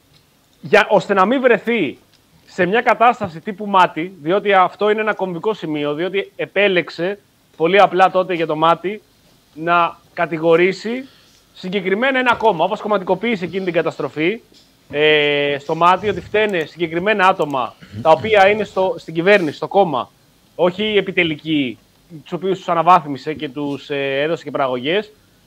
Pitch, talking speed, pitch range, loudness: 180 Hz, 145 wpm, 160-205 Hz, -17 LUFS